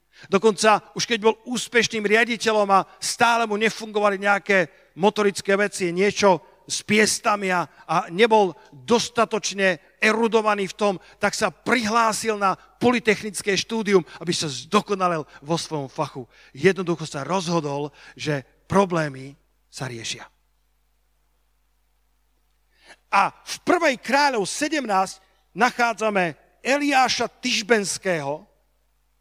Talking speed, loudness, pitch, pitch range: 105 wpm, -22 LUFS, 200 Hz, 175-225 Hz